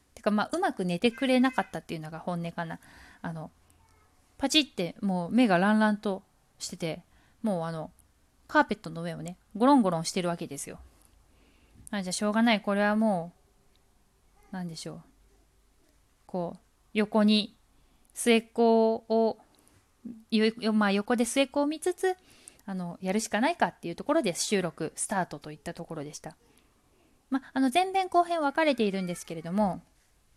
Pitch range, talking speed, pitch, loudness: 170-235 Hz, 290 characters per minute, 205 Hz, -28 LUFS